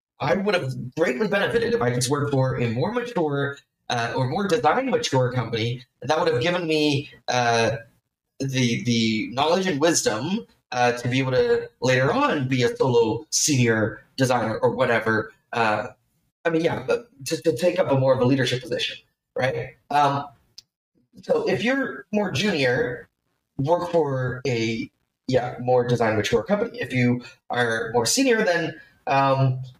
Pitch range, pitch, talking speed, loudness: 120-165 Hz, 135 Hz, 165 wpm, -23 LUFS